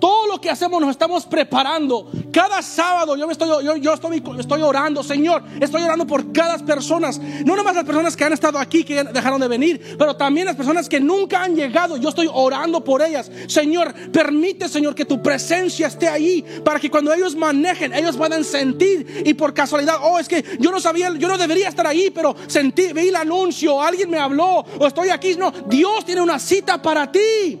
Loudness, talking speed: -18 LUFS, 210 wpm